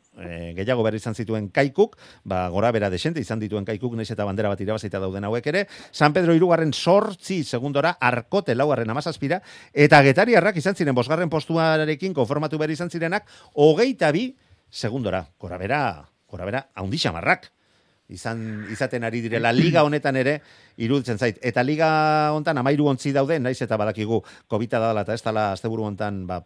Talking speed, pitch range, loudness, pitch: 170 wpm, 110-155 Hz, -22 LUFS, 125 Hz